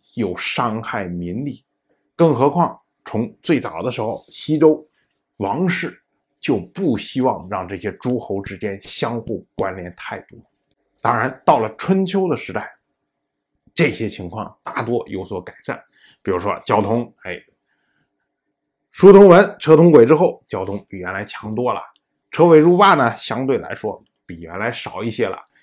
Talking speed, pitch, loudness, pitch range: 215 characters per minute, 135 Hz, -17 LUFS, 105-170 Hz